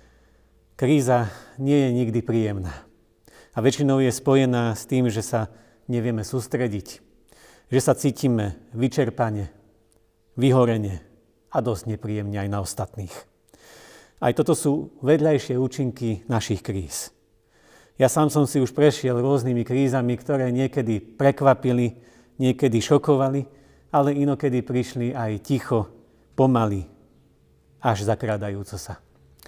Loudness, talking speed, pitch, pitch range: -23 LUFS, 110 wpm, 120 Hz, 105-135 Hz